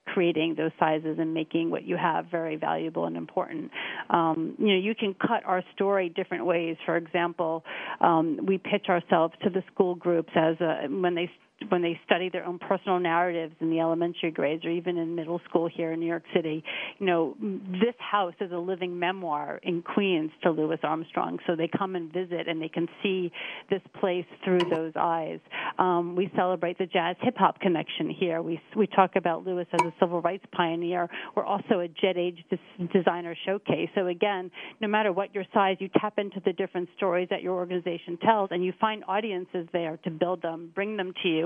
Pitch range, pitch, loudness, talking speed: 165-195 Hz, 180 Hz, -28 LUFS, 200 wpm